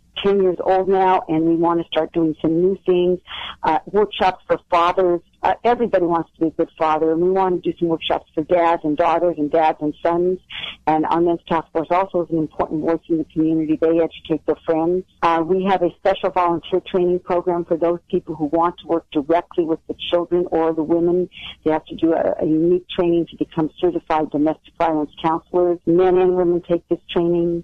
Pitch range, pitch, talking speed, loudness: 160-180 Hz, 170 Hz, 215 wpm, -19 LUFS